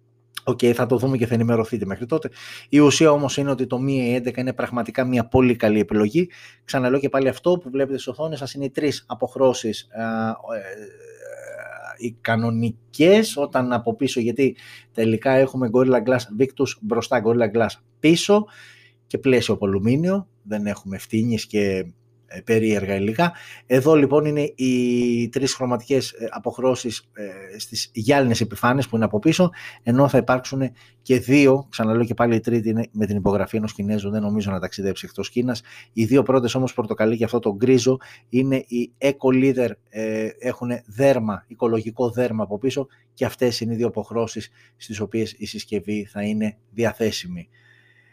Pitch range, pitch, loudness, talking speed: 110-130 Hz, 120 Hz, -21 LUFS, 160 wpm